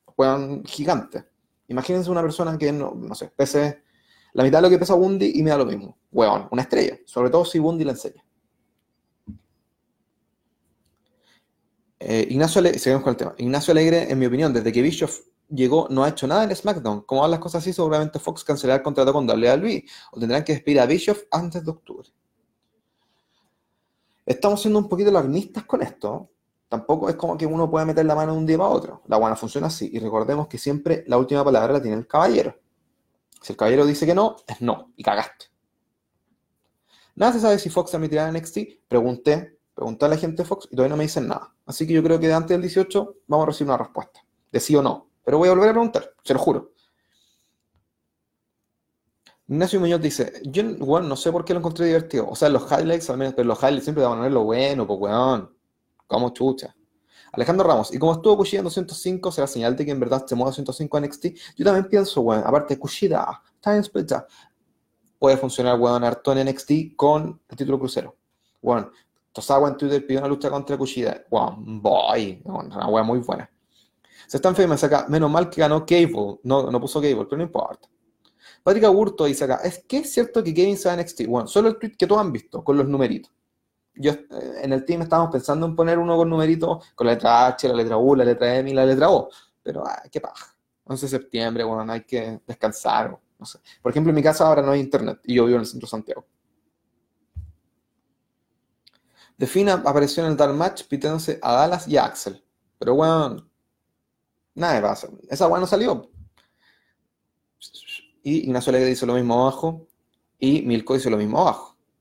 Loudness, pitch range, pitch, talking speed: -21 LUFS, 130-170 Hz, 150 Hz, 205 wpm